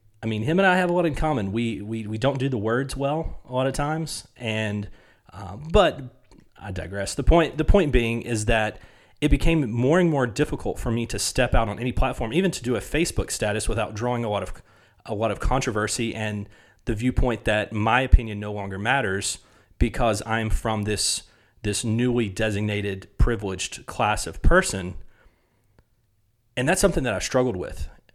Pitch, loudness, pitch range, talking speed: 115 Hz, -24 LUFS, 105-130 Hz, 190 wpm